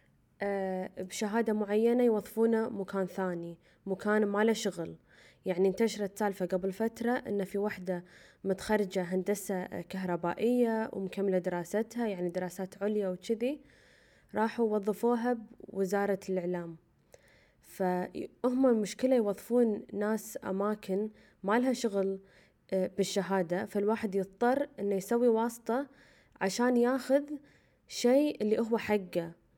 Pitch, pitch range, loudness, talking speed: 205 Hz, 190-230 Hz, -32 LUFS, 100 wpm